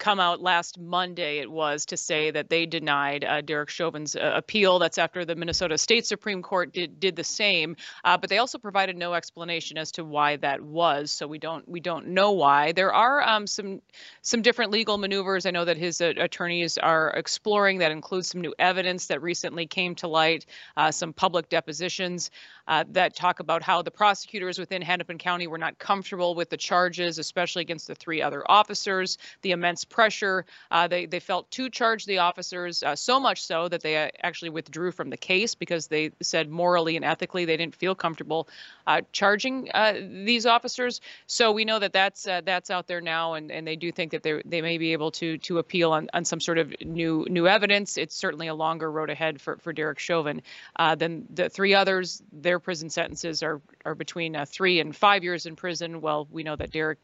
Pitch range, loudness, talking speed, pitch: 160-185 Hz, -25 LUFS, 210 wpm, 175 Hz